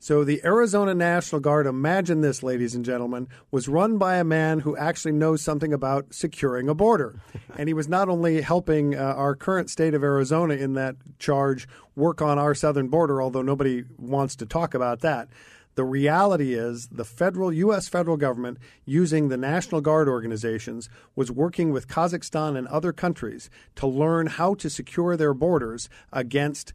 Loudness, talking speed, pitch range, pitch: -24 LUFS, 175 wpm, 130-165 Hz, 150 Hz